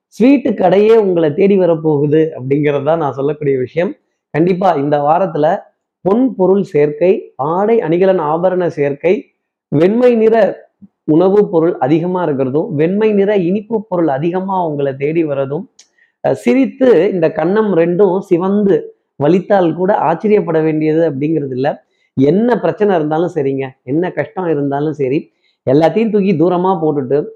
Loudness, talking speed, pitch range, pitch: -13 LUFS, 125 wpm, 150-200 Hz, 170 Hz